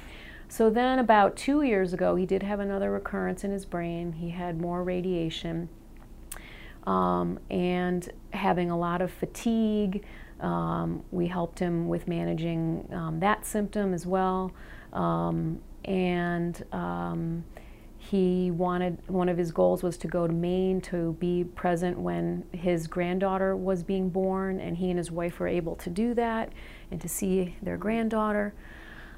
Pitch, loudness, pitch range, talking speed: 180 Hz, -29 LUFS, 170-190 Hz, 150 wpm